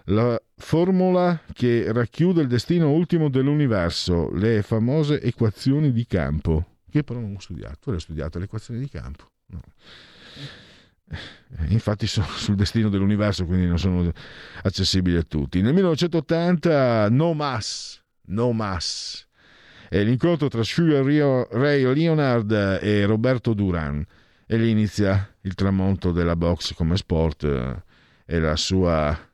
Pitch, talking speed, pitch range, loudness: 105 Hz, 130 wpm, 90-130 Hz, -22 LUFS